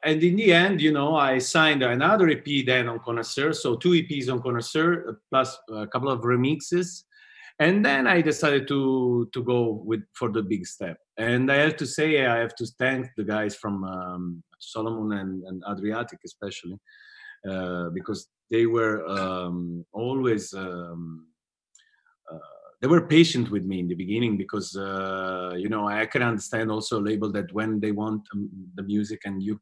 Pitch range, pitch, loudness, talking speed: 100-135 Hz, 115 Hz, -25 LUFS, 175 wpm